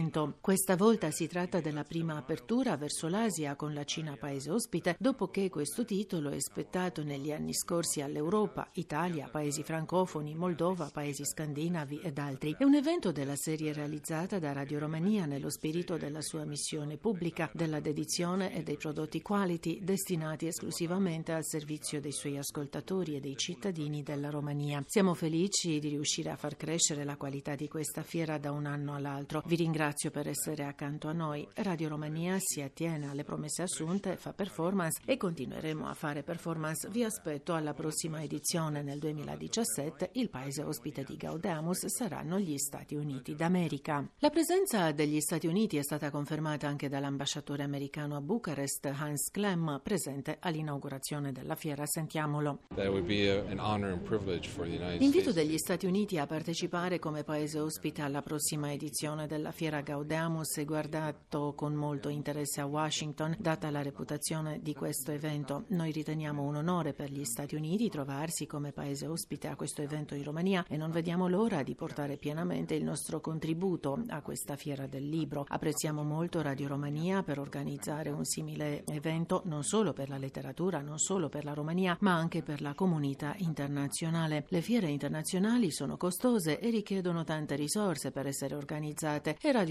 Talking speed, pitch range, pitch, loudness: 160 wpm, 145-175 Hz, 155 Hz, -34 LUFS